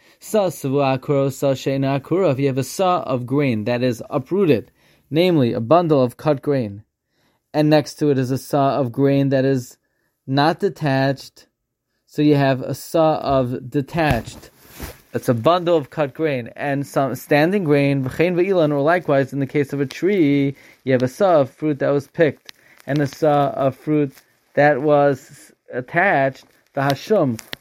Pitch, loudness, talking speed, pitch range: 140 Hz, -19 LUFS, 160 wpm, 130-150 Hz